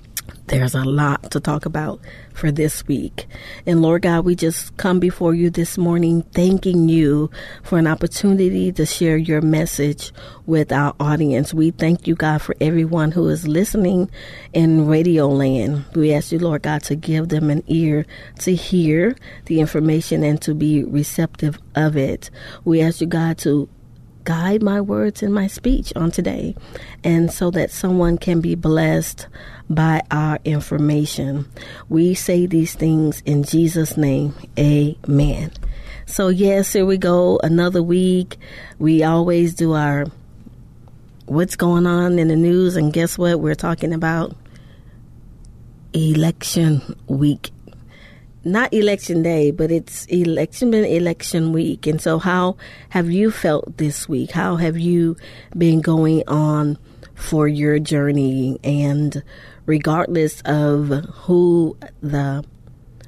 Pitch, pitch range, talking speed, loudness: 160 Hz, 145-170 Hz, 145 wpm, -18 LUFS